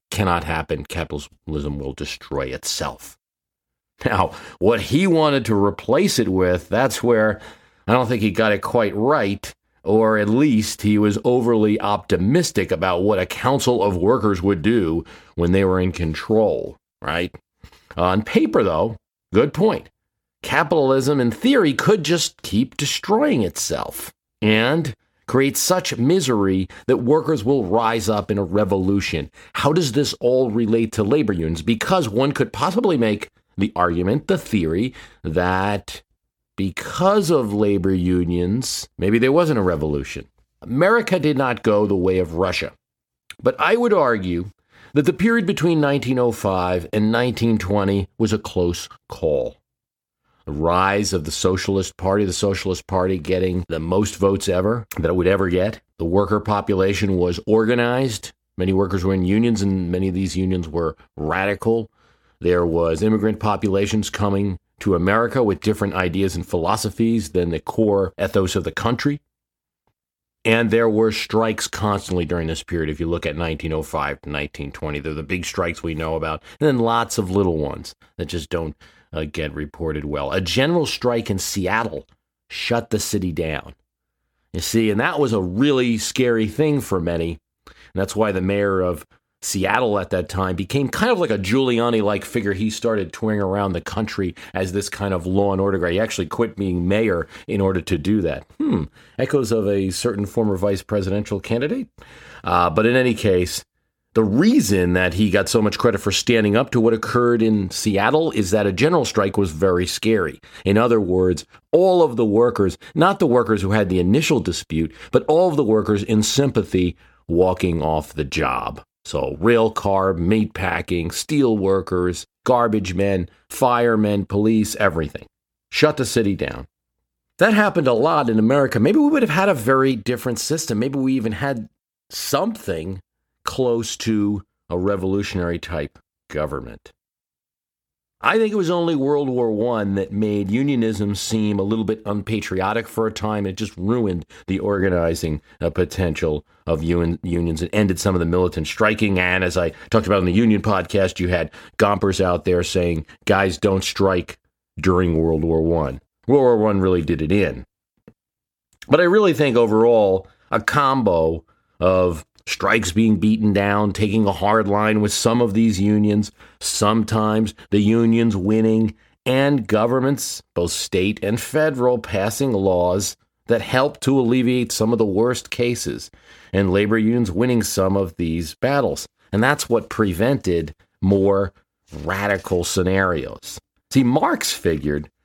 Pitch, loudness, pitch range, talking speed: 100 Hz, -20 LUFS, 90-115 Hz, 165 wpm